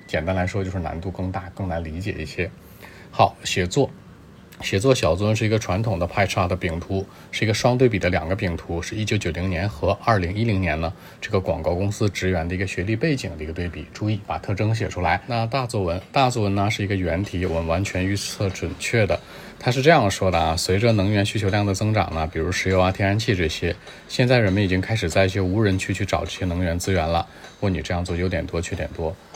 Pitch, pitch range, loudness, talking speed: 95 Hz, 90-105 Hz, -23 LUFS, 350 characters per minute